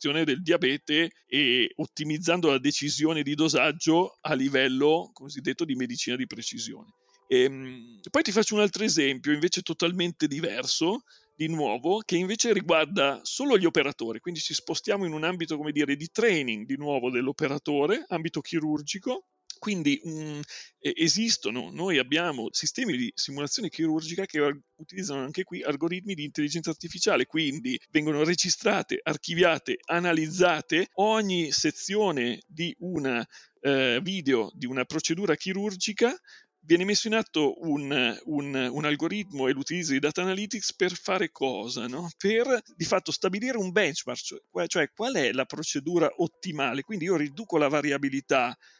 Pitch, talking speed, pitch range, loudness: 165 Hz, 145 wpm, 145-195 Hz, -27 LUFS